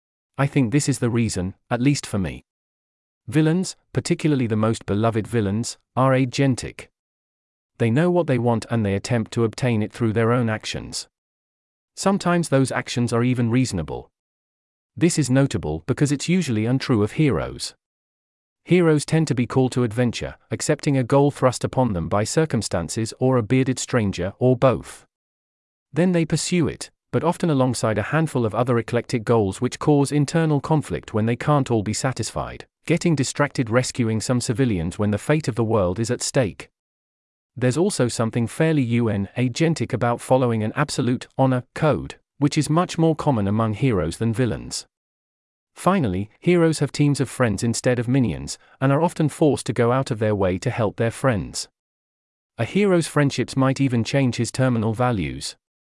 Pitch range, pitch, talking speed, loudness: 105-140 Hz, 125 Hz, 170 wpm, -22 LUFS